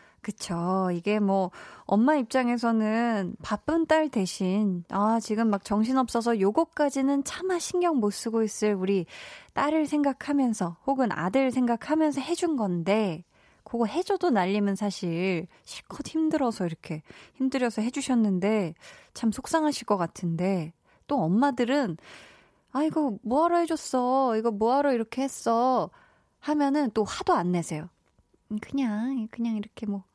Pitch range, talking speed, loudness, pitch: 200-280 Hz, 285 characters per minute, -27 LUFS, 230 Hz